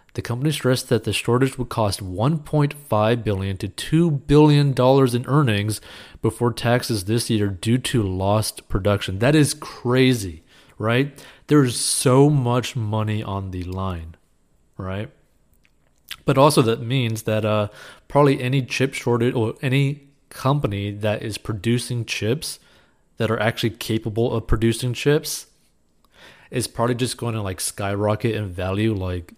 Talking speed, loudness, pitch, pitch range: 145 wpm, -21 LUFS, 115 Hz, 105-135 Hz